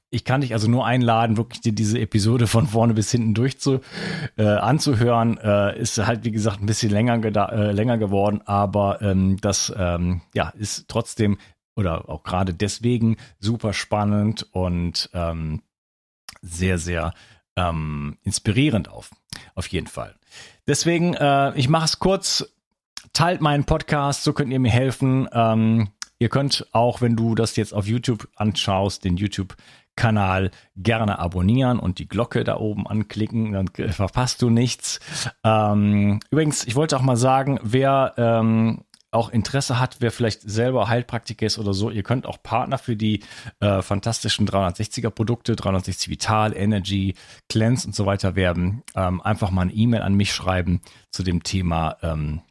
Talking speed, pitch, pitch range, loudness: 160 wpm, 110 Hz, 100-120 Hz, -22 LUFS